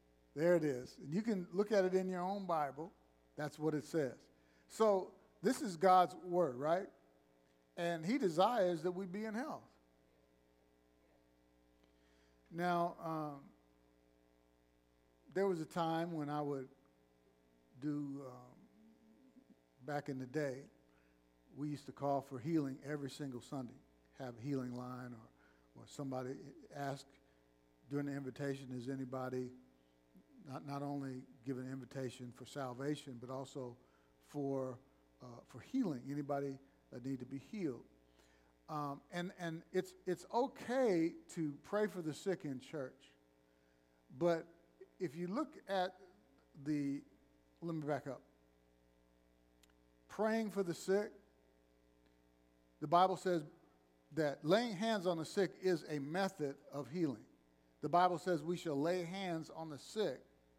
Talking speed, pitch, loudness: 140 wpm, 140 Hz, -40 LUFS